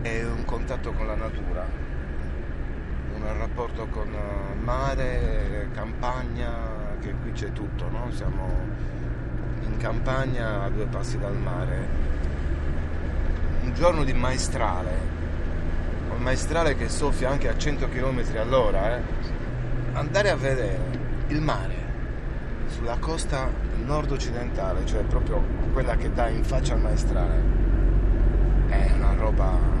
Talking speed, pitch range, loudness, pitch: 115 wpm, 70-115 Hz, -28 LUFS, 80 Hz